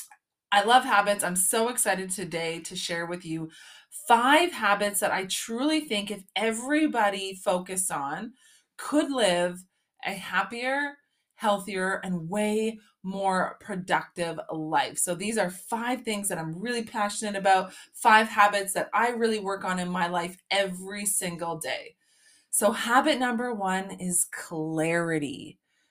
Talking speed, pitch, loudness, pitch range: 140 wpm, 200 Hz, -26 LUFS, 180-230 Hz